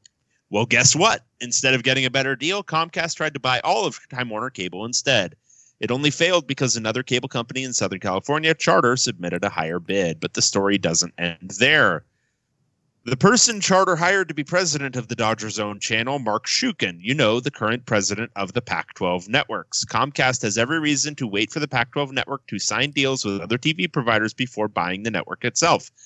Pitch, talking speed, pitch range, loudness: 125 Hz, 200 wpm, 110-145 Hz, -21 LUFS